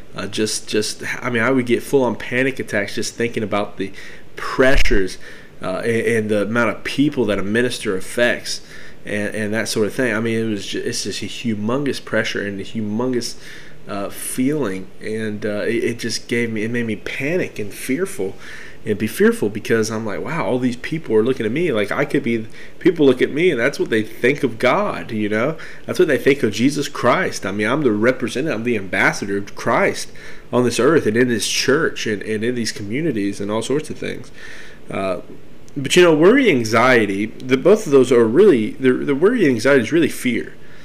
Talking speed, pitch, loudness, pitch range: 210 wpm, 115 Hz, -19 LUFS, 105-125 Hz